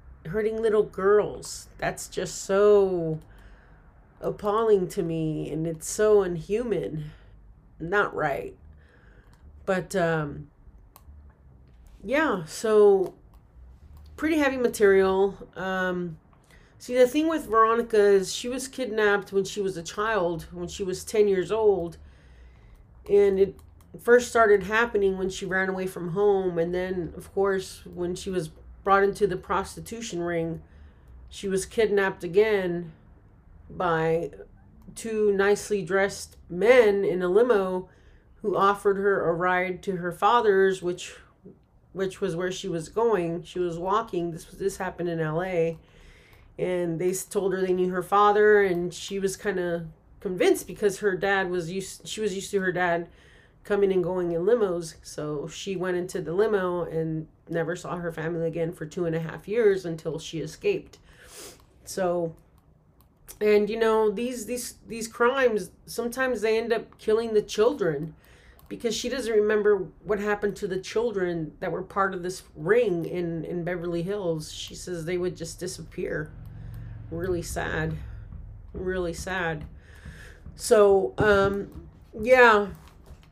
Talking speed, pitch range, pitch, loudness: 145 wpm, 165-205 Hz, 185 Hz, -25 LUFS